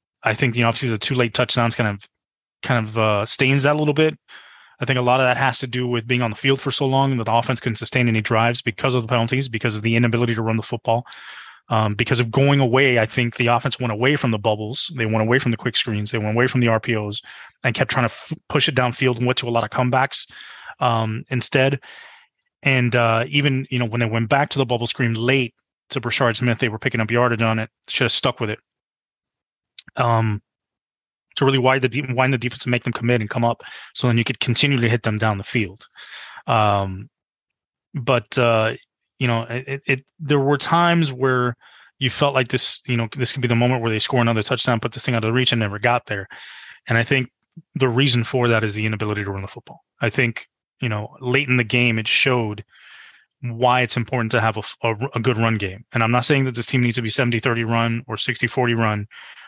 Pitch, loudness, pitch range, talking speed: 120 Hz, -20 LUFS, 115-130 Hz, 245 wpm